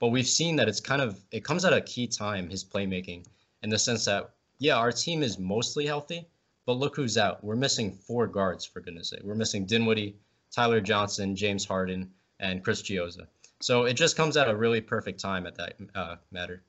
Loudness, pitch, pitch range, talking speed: -28 LUFS, 110 Hz, 95-120 Hz, 210 wpm